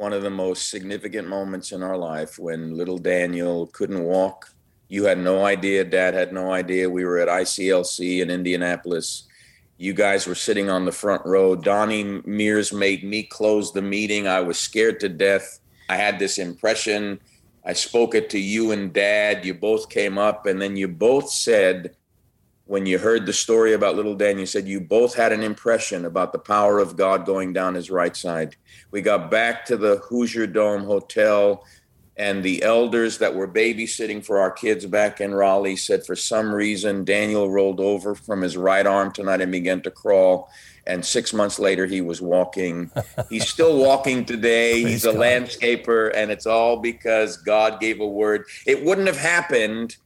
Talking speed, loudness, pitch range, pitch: 185 wpm, -21 LUFS, 95-110 Hz, 100 Hz